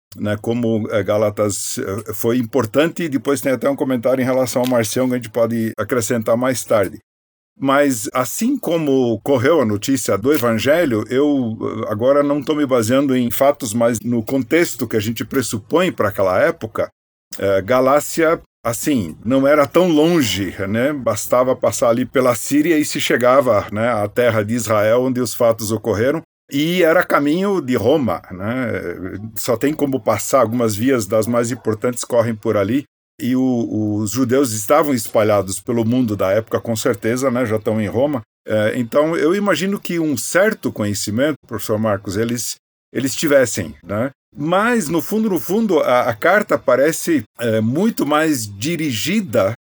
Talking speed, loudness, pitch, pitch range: 160 wpm, -17 LUFS, 125 Hz, 110-145 Hz